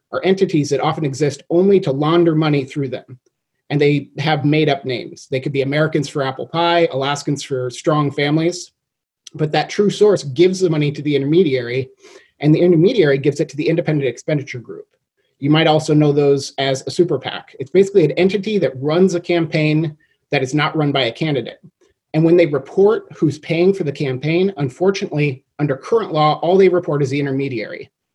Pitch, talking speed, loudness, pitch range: 155 Hz, 195 wpm, -17 LUFS, 140-175 Hz